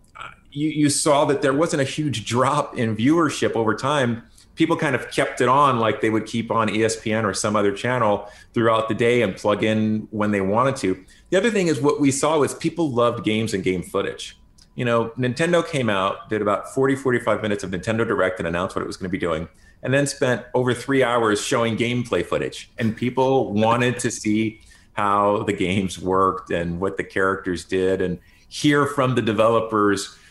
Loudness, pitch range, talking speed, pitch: -21 LUFS, 100-130 Hz, 205 wpm, 110 Hz